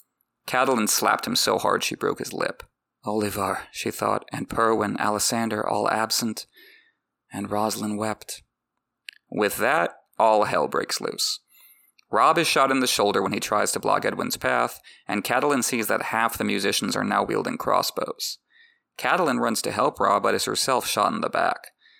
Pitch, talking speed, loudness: 110 Hz, 170 wpm, -23 LUFS